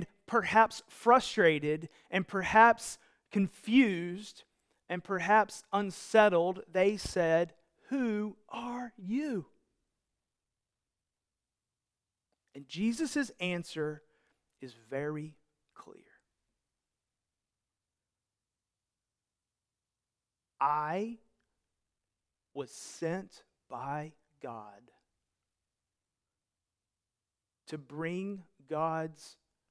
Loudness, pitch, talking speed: -31 LUFS, 155 Hz, 55 wpm